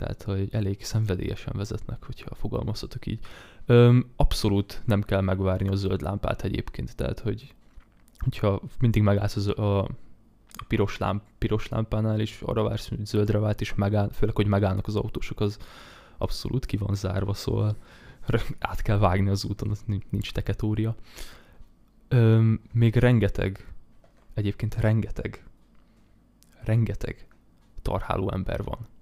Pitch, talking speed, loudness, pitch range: 105 Hz, 135 wpm, -26 LUFS, 100-115 Hz